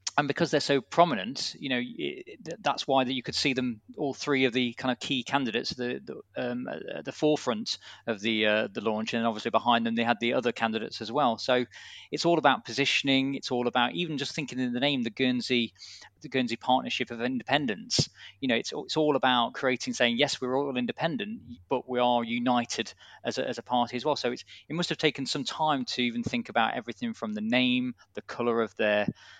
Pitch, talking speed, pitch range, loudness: 125 Hz, 225 wpm, 120-145 Hz, -28 LUFS